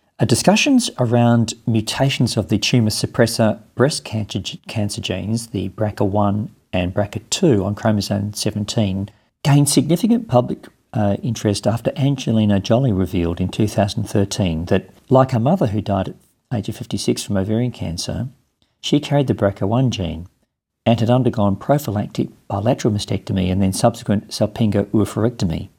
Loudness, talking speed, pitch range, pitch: -19 LUFS, 135 wpm, 100-120 Hz, 110 Hz